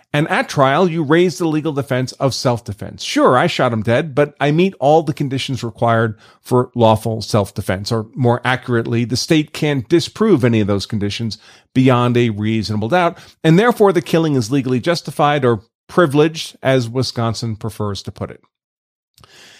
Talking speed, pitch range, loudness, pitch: 175 wpm, 115-155 Hz, -16 LUFS, 125 Hz